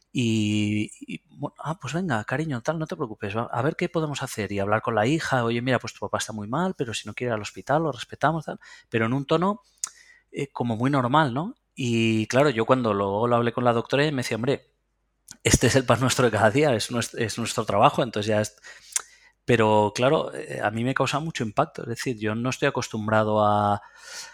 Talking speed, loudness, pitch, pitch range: 230 wpm, -25 LUFS, 120 Hz, 110-140 Hz